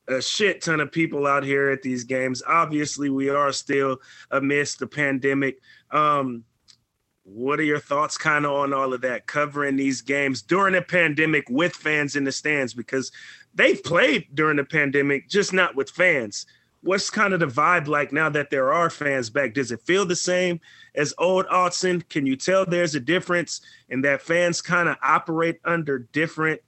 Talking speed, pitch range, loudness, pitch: 185 wpm, 135-170 Hz, -22 LUFS, 145 Hz